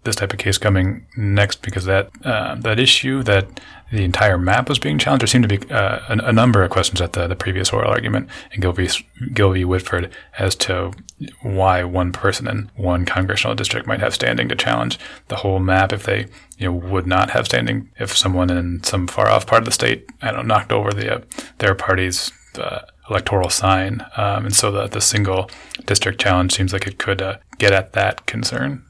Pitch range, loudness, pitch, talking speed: 95-110 Hz, -18 LUFS, 95 Hz, 205 wpm